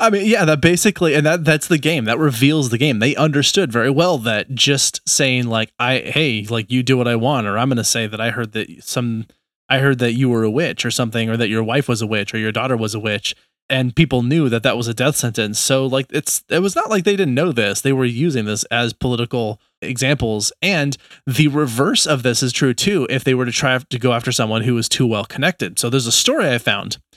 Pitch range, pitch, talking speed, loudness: 115-150 Hz, 130 Hz, 260 wpm, -17 LUFS